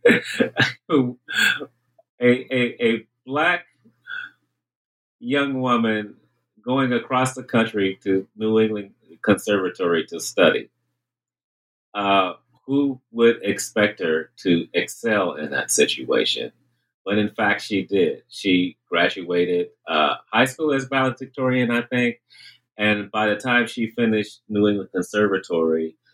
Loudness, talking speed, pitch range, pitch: -21 LUFS, 115 wpm, 100-130 Hz, 115 Hz